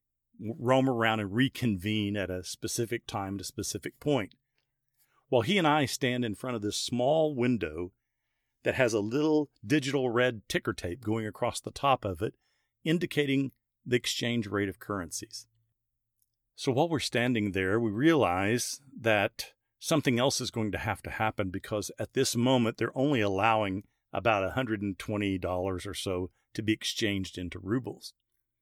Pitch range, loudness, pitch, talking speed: 105-125 Hz, -30 LUFS, 115 Hz, 155 wpm